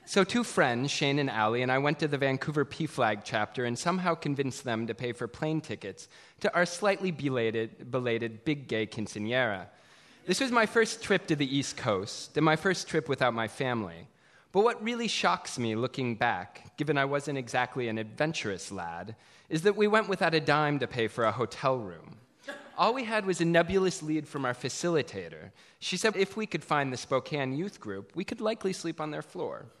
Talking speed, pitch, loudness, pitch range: 205 wpm, 140 Hz, -30 LUFS, 120-175 Hz